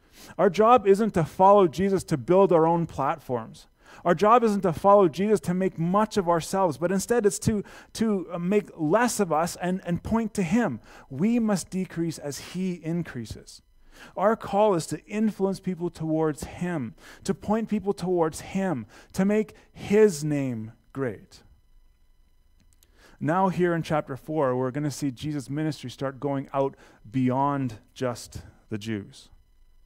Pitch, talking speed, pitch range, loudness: 170 Hz, 155 wpm, 135-195 Hz, -25 LUFS